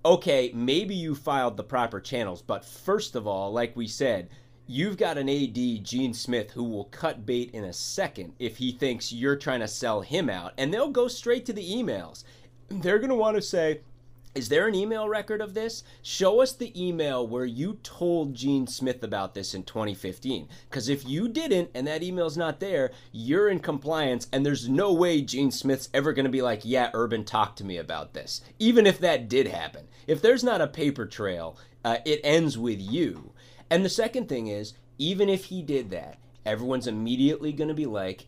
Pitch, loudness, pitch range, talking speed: 135 Hz, -27 LUFS, 120-170 Hz, 205 wpm